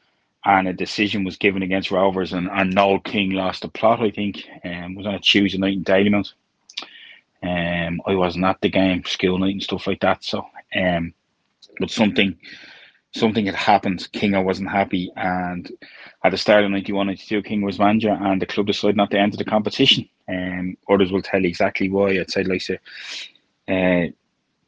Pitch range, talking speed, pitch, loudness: 90-100 Hz, 190 wpm, 95 Hz, -20 LUFS